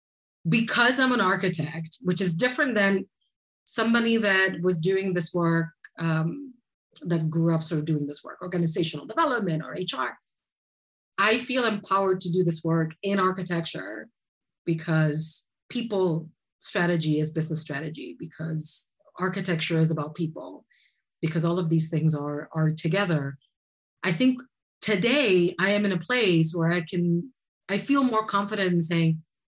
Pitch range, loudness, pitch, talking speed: 160-200 Hz, -25 LUFS, 175 Hz, 145 wpm